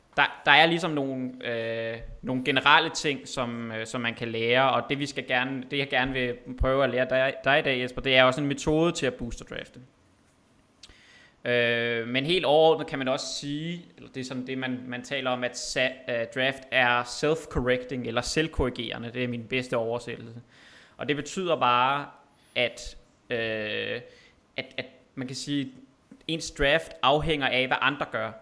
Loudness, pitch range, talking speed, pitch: -26 LUFS, 120-140 Hz, 190 wpm, 130 Hz